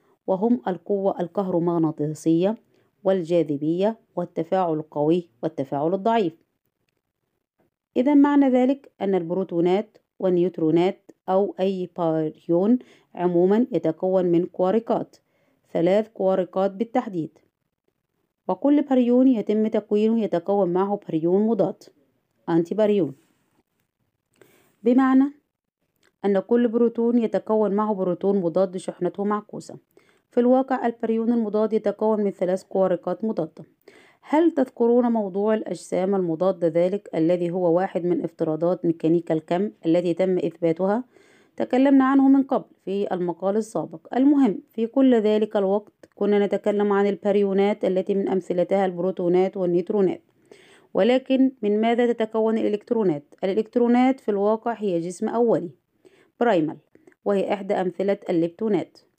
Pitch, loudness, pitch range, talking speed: 200 Hz, -22 LUFS, 180-230 Hz, 105 wpm